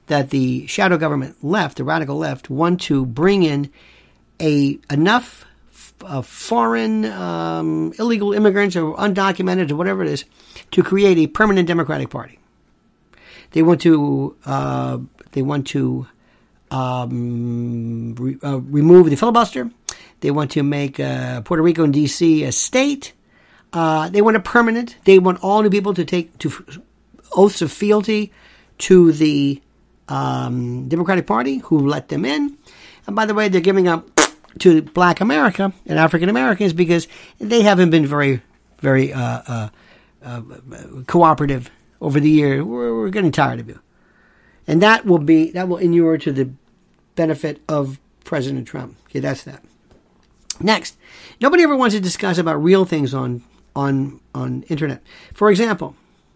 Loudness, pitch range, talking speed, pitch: -17 LUFS, 135-185 Hz, 155 wpm, 160 Hz